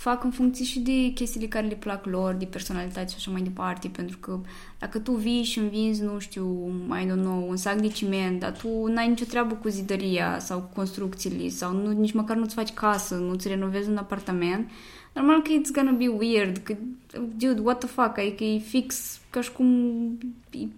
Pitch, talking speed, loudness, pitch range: 215 Hz, 205 wpm, -27 LUFS, 190-240 Hz